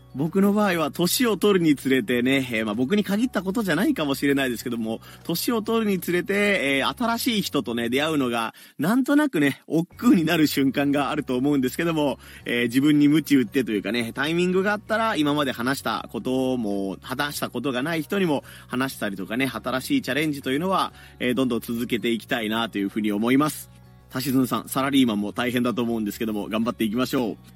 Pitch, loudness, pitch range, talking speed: 135 Hz, -23 LUFS, 120-170 Hz, 455 characters per minute